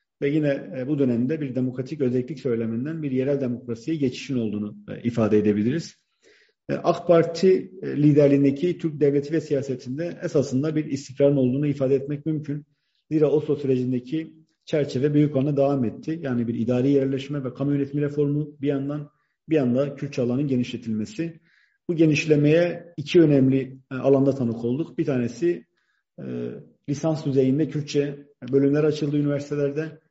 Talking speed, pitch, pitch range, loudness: 135 wpm, 140 Hz, 130-155 Hz, -23 LUFS